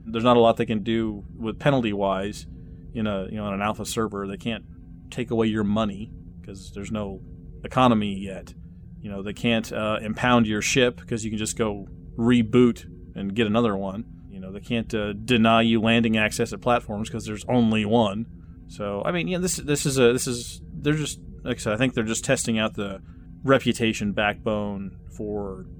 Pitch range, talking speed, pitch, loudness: 100-120 Hz, 200 wpm, 110 Hz, -24 LUFS